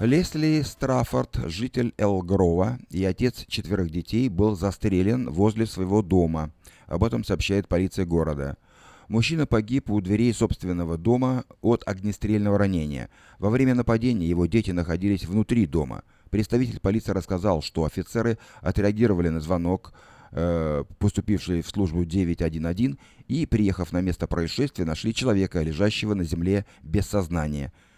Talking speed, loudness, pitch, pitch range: 125 wpm, -25 LUFS, 100 Hz, 85-115 Hz